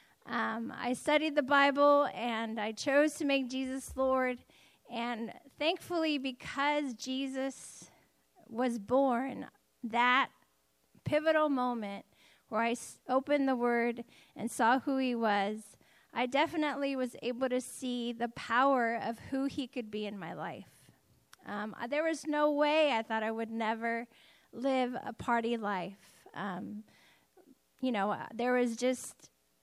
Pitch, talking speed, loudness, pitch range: 250 Hz, 140 wpm, -33 LUFS, 230-280 Hz